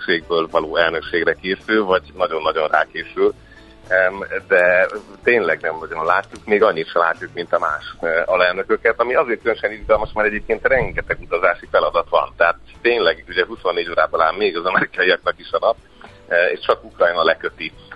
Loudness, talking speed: -18 LUFS, 155 wpm